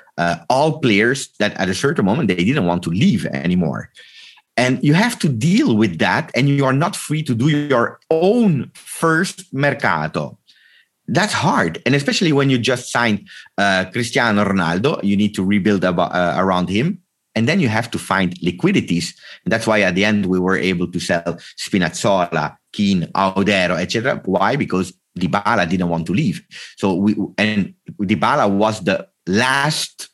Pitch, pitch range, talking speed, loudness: 110 Hz, 95-150 Hz, 175 wpm, -18 LUFS